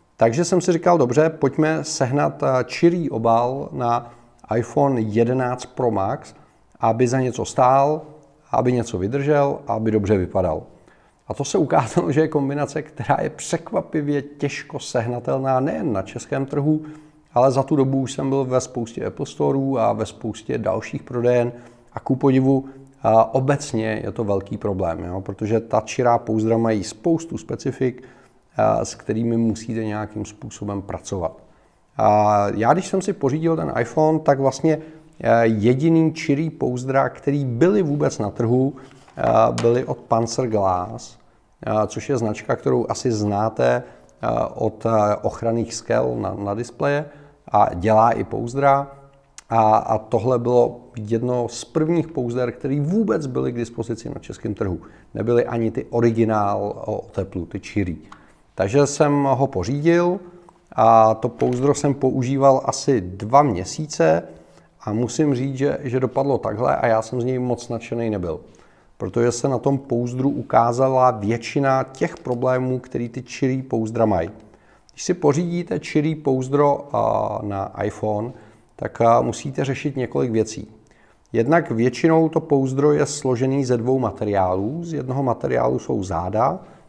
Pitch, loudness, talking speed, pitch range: 125 Hz, -21 LUFS, 140 wpm, 110-140 Hz